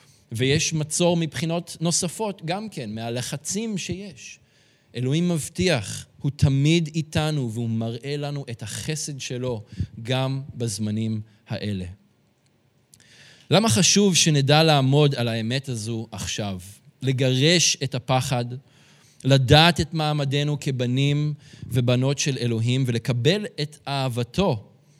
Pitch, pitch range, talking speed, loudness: 140 Hz, 120-155 Hz, 105 wpm, -23 LUFS